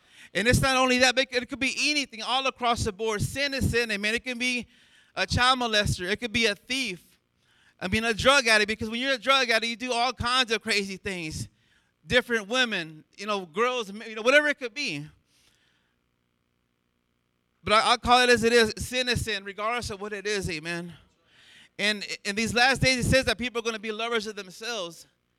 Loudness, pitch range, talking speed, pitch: -25 LUFS, 190-250 Hz, 215 wpm, 225 Hz